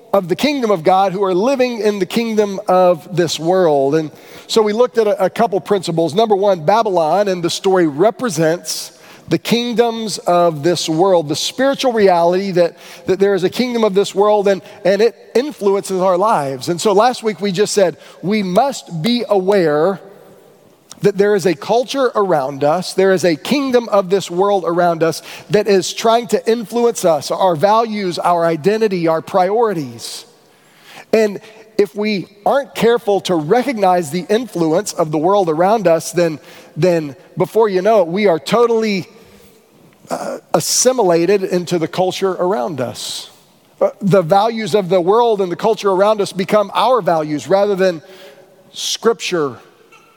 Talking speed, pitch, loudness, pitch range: 165 wpm, 195 Hz, -15 LUFS, 175-220 Hz